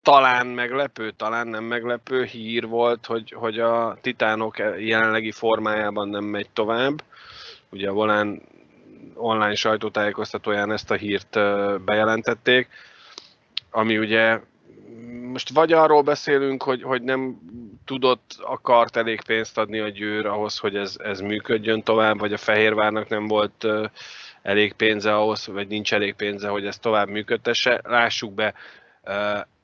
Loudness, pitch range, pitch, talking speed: -22 LUFS, 105-120 Hz, 110 Hz, 130 wpm